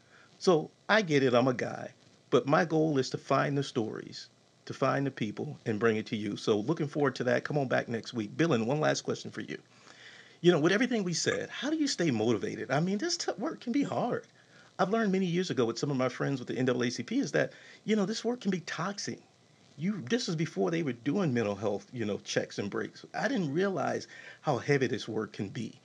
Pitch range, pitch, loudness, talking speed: 125-195 Hz, 155 Hz, -31 LUFS, 245 wpm